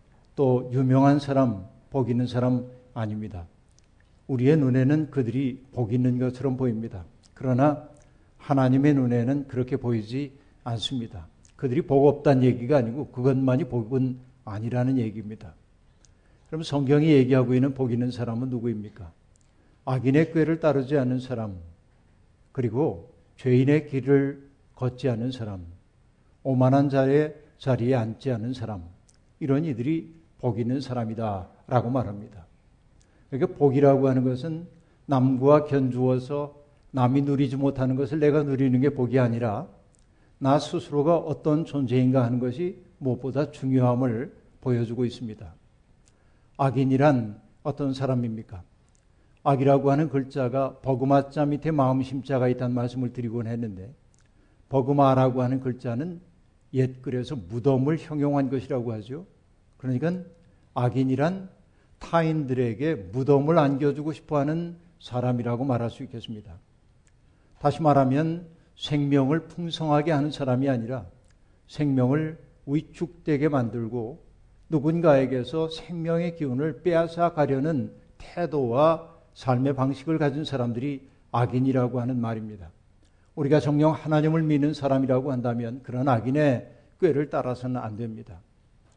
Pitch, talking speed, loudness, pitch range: 130 Hz, 300 characters per minute, -25 LUFS, 120-145 Hz